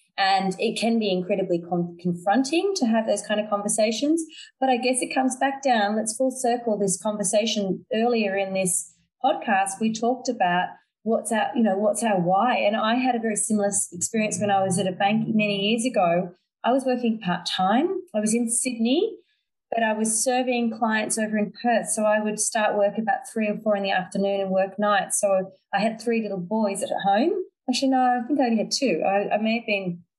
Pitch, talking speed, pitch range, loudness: 215 Hz, 215 wpm, 195-240 Hz, -23 LUFS